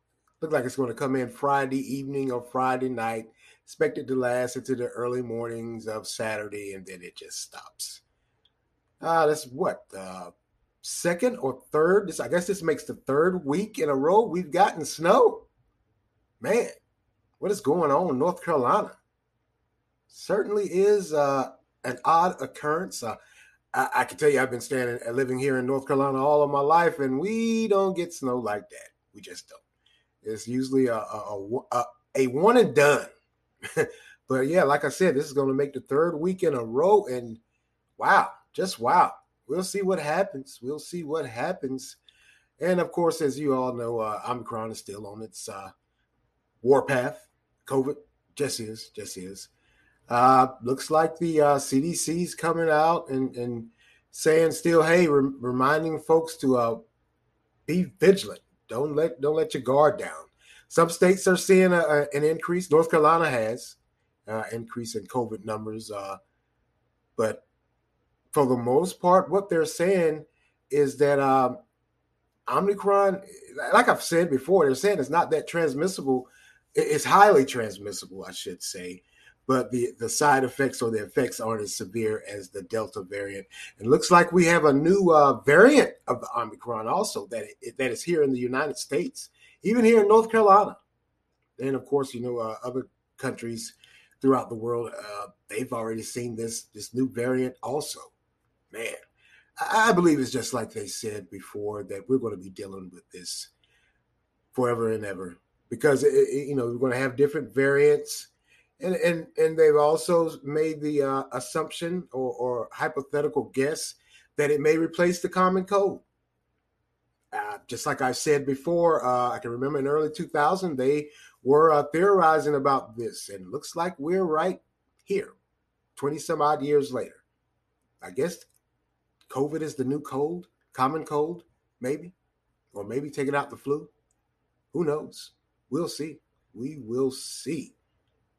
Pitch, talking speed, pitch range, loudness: 140 Hz, 170 wpm, 125-170 Hz, -25 LUFS